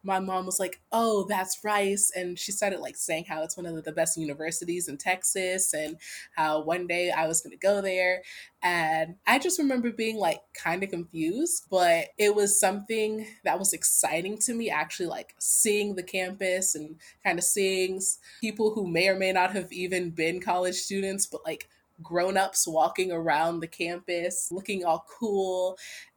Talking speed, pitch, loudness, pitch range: 180 wpm, 185 Hz, -27 LUFS, 170-205 Hz